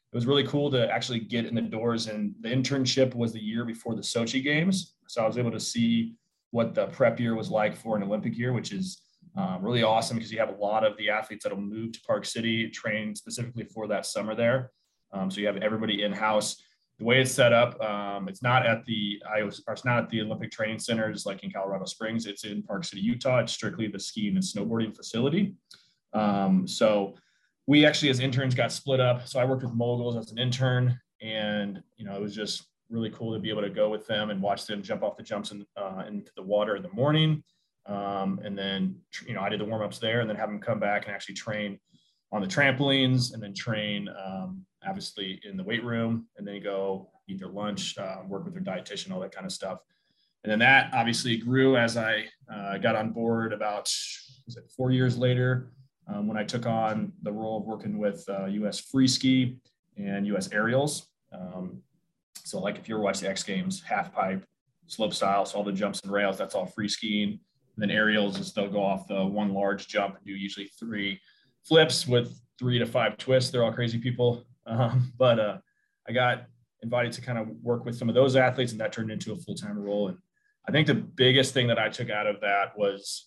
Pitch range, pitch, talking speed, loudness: 105-130 Hz, 115 Hz, 230 wpm, -28 LUFS